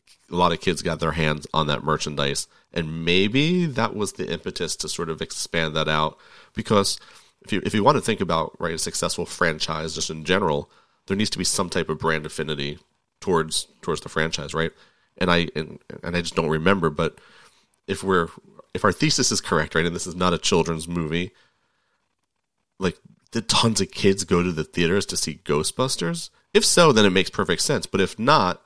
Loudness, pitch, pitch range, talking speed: -23 LUFS, 85 Hz, 80-95 Hz, 205 wpm